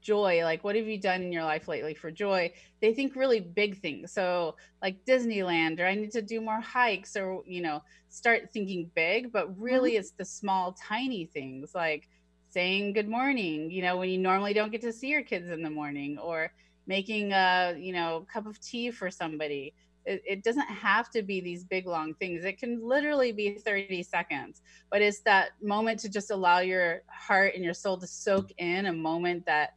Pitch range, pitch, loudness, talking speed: 170-215 Hz, 190 Hz, -30 LUFS, 205 wpm